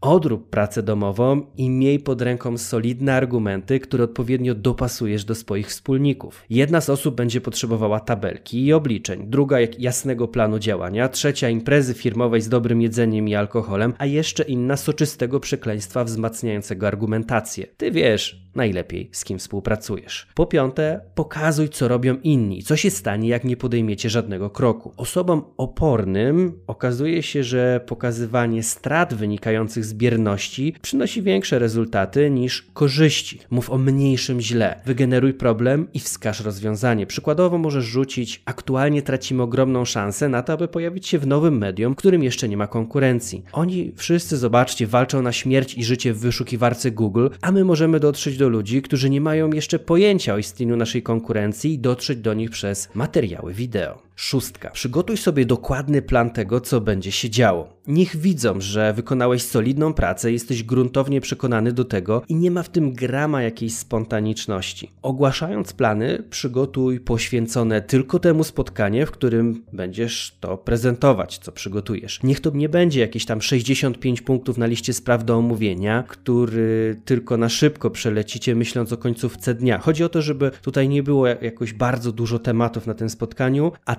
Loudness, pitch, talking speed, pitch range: -21 LUFS, 125 Hz, 160 wpm, 115-140 Hz